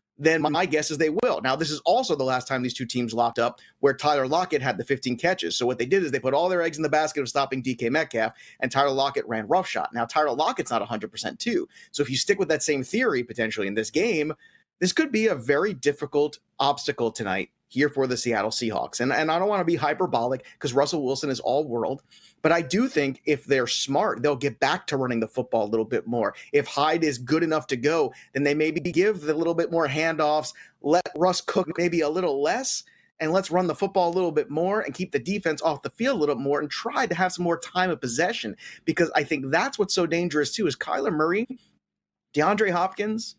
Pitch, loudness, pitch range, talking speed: 150 Hz, -25 LUFS, 135-170 Hz, 240 wpm